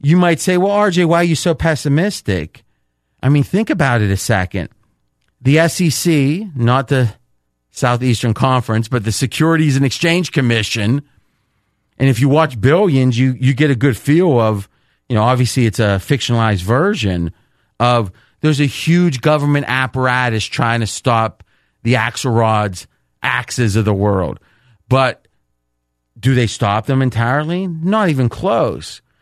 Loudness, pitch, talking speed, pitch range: -15 LUFS, 125 Hz, 150 wpm, 110-145 Hz